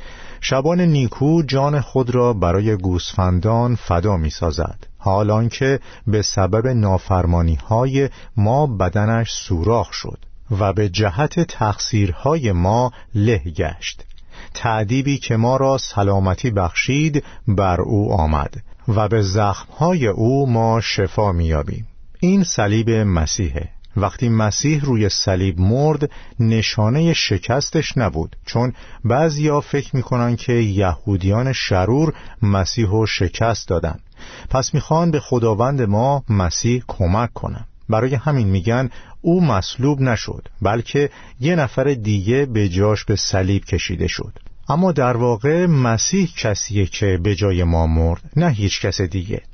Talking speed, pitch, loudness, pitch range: 125 wpm, 110 Hz, -18 LUFS, 95-130 Hz